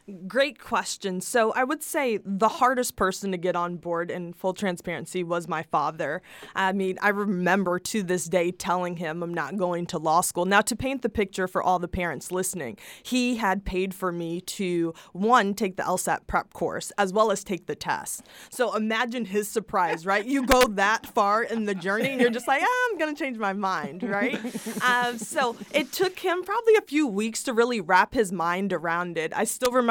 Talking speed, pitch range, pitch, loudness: 210 wpm, 180-240 Hz, 200 Hz, -26 LUFS